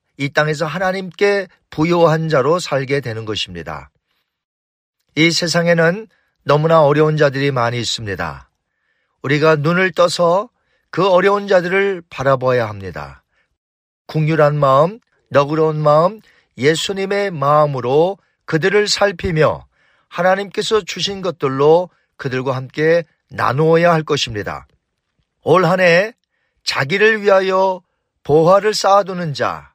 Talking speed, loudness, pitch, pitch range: 260 characters per minute, -15 LUFS, 160 Hz, 135-185 Hz